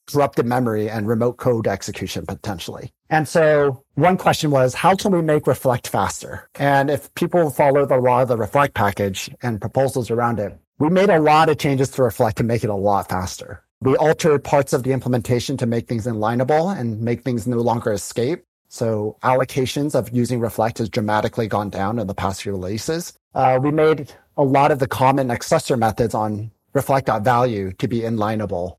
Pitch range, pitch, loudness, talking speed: 110-140 Hz, 125 Hz, -19 LUFS, 190 wpm